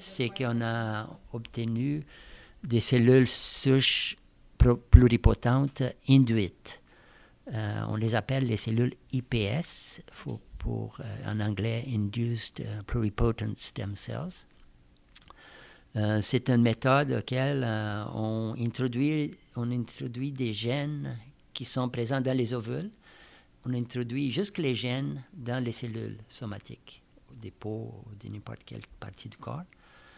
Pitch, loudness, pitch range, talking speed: 120 Hz, -29 LUFS, 110-130 Hz, 125 wpm